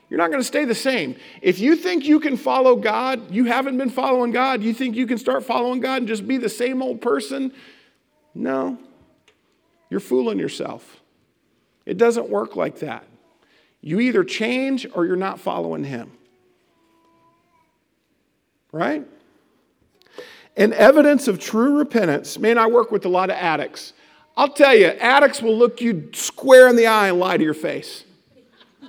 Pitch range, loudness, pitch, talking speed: 230-285 Hz, -18 LUFS, 255 Hz, 165 wpm